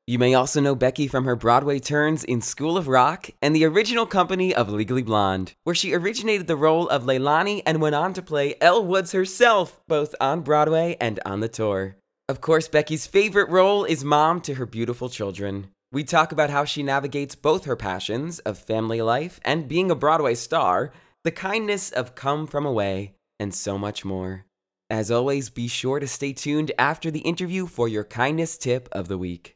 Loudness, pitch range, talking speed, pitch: -23 LUFS, 115-160 Hz, 195 wpm, 140 Hz